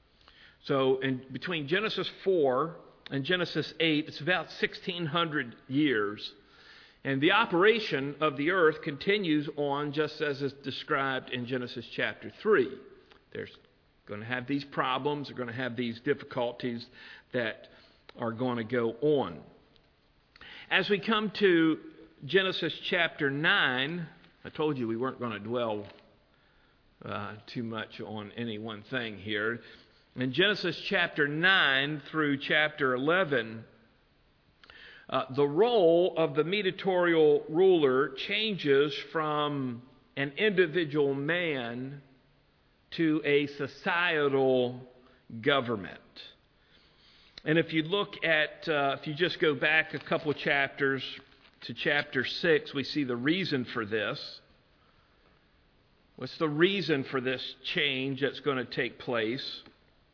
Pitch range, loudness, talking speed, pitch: 125-160 Hz, -29 LUFS, 125 wpm, 140 Hz